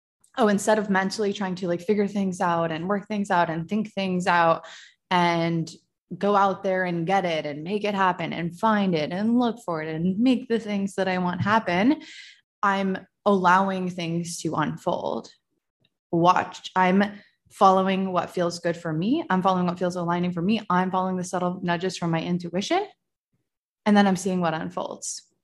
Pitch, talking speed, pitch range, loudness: 185 Hz, 185 wpm, 175-205 Hz, -24 LUFS